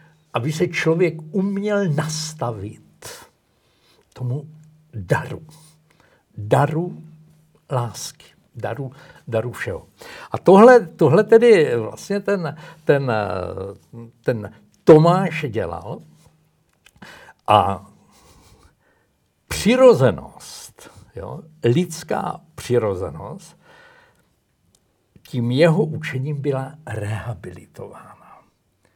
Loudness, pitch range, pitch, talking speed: -19 LUFS, 120-165 Hz, 155 Hz, 65 wpm